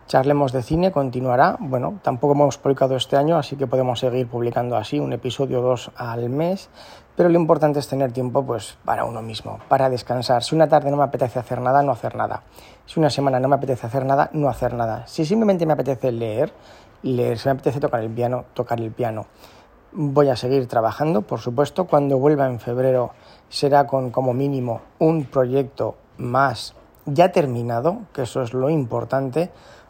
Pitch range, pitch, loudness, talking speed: 125-145 Hz, 135 Hz, -21 LUFS, 190 wpm